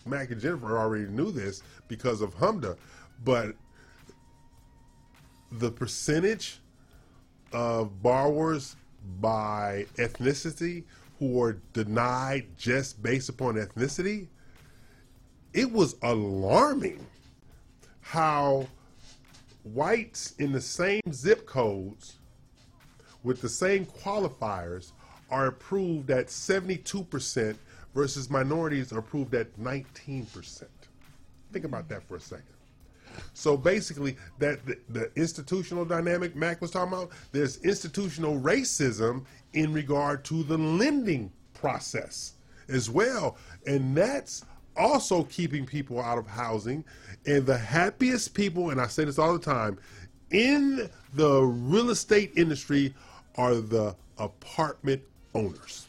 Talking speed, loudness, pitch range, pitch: 110 wpm, -29 LUFS, 120-165 Hz, 135 Hz